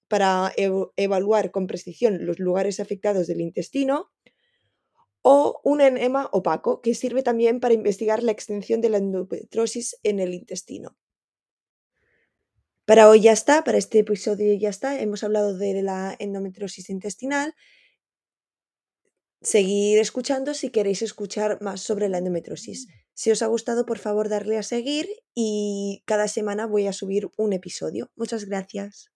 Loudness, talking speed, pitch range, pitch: -22 LUFS, 140 wpm, 195-235 Hz, 210 Hz